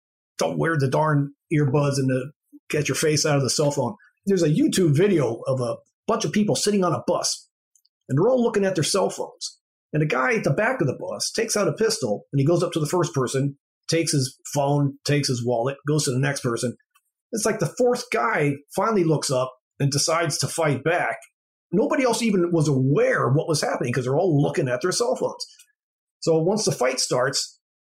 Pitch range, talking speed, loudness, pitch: 140-185 Hz, 220 wpm, -23 LUFS, 155 Hz